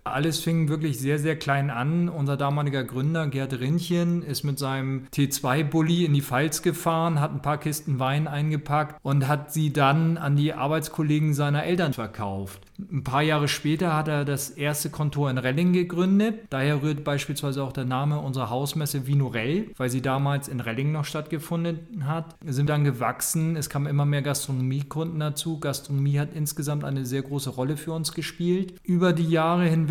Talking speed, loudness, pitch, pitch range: 185 wpm, -25 LUFS, 150 Hz, 140-160 Hz